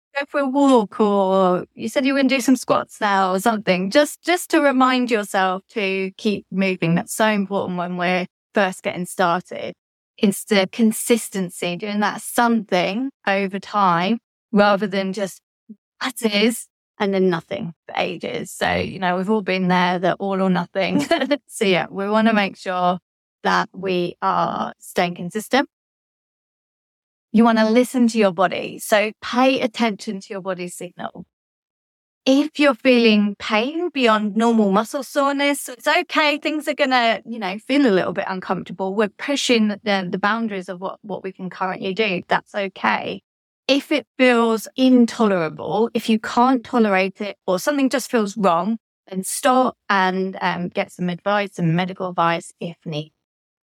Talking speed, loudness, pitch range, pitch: 165 wpm, -20 LUFS, 185-240 Hz, 205 Hz